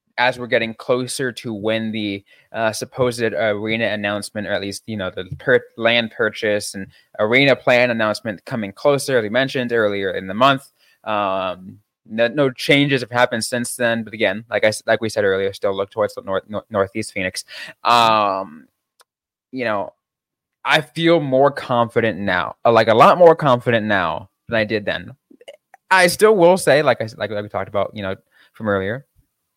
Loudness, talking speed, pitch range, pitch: -18 LUFS, 180 wpm, 105-130 Hz, 115 Hz